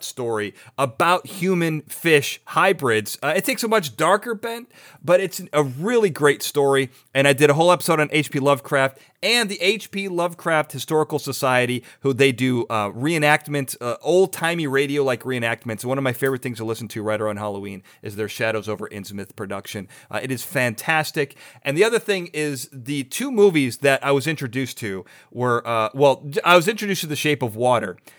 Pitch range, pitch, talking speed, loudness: 125-165 Hz, 140 Hz, 185 wpm, -21 LUFS